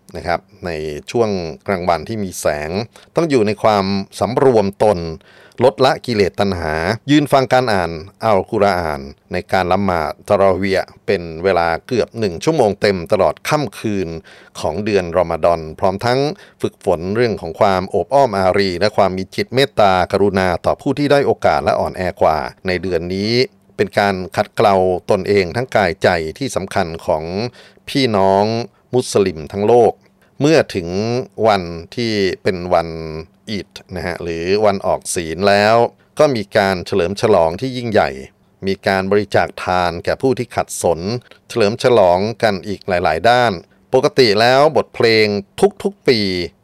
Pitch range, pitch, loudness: 90-115 Hz, 100 Hz, -16 LUFS